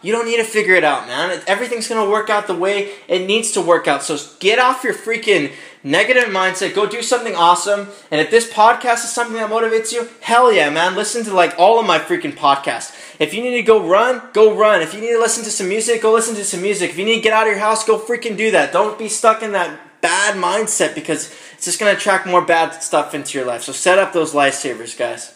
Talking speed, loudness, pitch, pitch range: 255 wpm, -16 LUFS, 215 Hz, 180-230 Hz